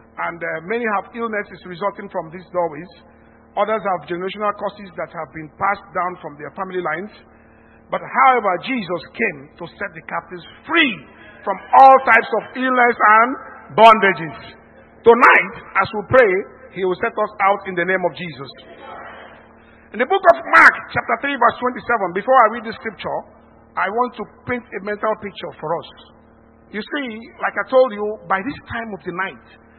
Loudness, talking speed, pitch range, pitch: -17 LUFS, 175 wpm, 180-230 Hz, 200 Hz